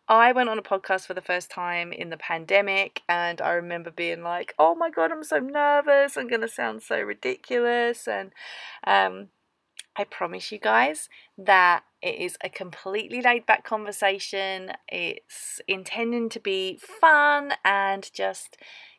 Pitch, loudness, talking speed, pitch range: 200 Hz, -24 LUFS, 160 wpm, 175-250 Hz